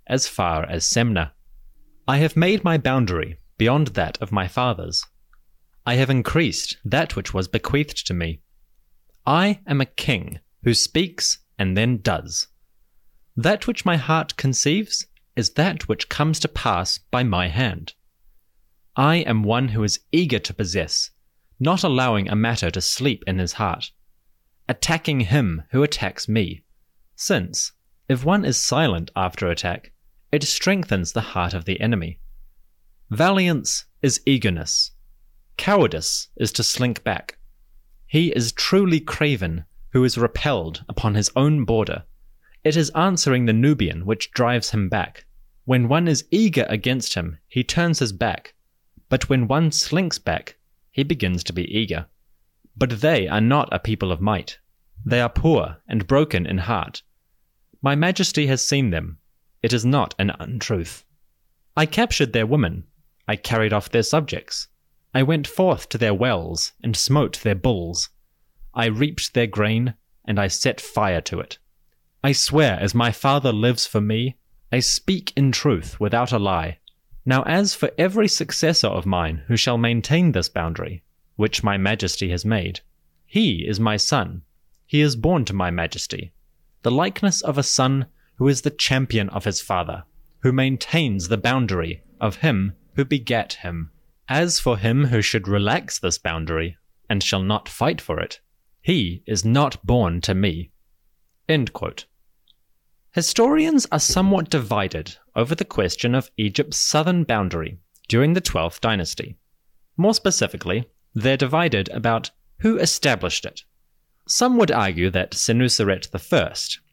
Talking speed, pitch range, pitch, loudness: 155 wpm, 90-140 Hz, 110 Hz, -21 LUFS